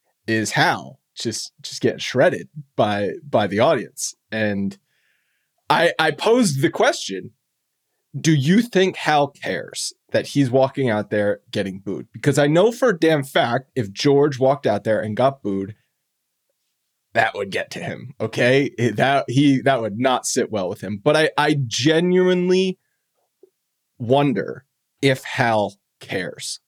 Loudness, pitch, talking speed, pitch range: -20 LUFS, 140 Hz, 150 wpm, 110-160 Hz